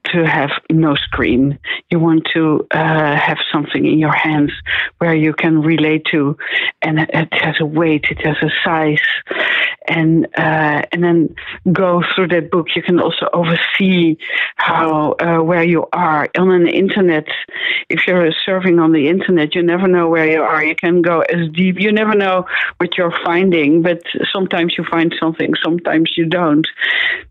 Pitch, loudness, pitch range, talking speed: 165 Hz, -14 LUFS, 155-175 Hz, 170 wpm